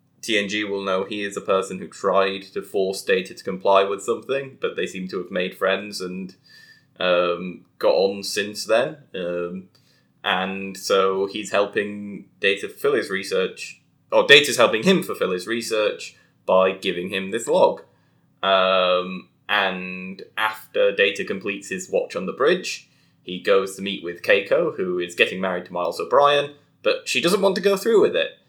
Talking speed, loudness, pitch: 175 wpm, -21 LUFS, 100 Hz